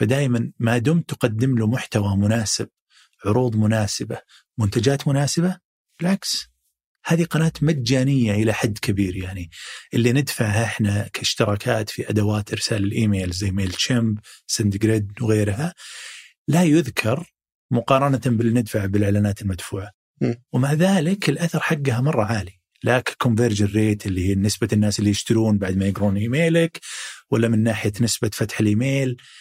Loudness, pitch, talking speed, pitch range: -21 LUFS, 115 Hz, 130 wpm, 105-135 Hz